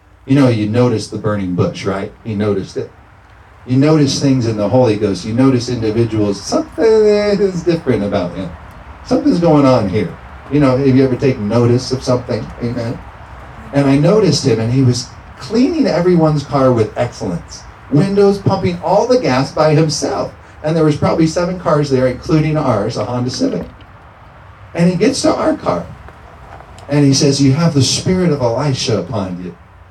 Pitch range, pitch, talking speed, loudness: 105-155 Hz, 130 Hz, 175 wpm, -14 LUFS